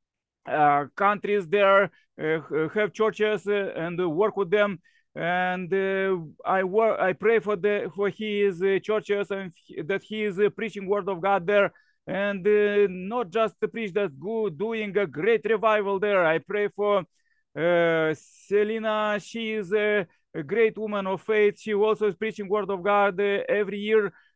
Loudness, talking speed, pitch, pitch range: -25 LUFS, 170 wpm, 205 Hz, 195-215 Hz